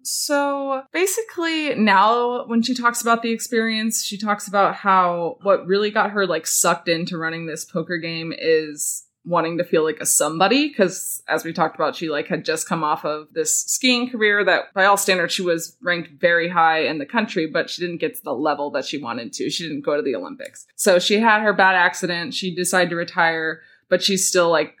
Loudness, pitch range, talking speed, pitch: -20 LUFS, 165-225 Hz, 215 wpm, 180 Hz